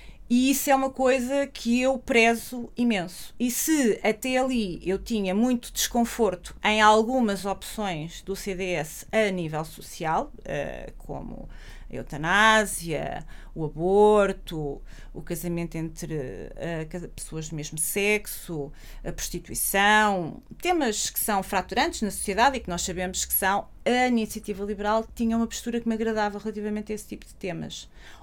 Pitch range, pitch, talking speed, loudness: 175-230 Hz, 210 Hz, 140 wpm, -25 LUFS